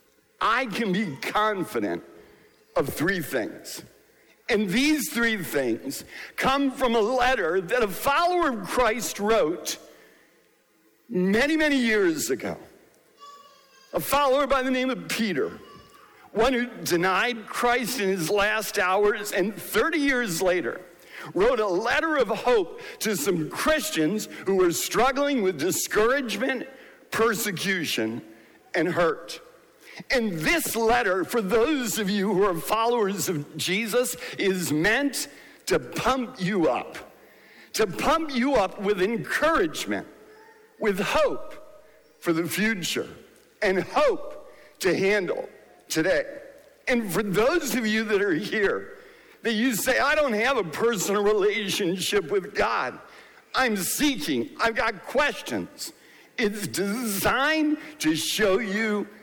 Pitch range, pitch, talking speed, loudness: 200-295 Hz, 235 Hz, 125 wpm, -25 LUFS